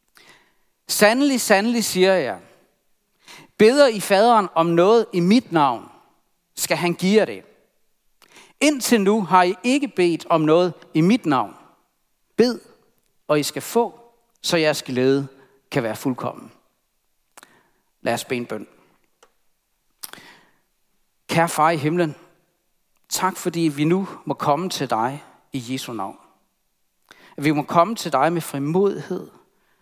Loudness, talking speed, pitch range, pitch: -20 LUFS, 135 wpm, 150-210 Hz, 175 Hz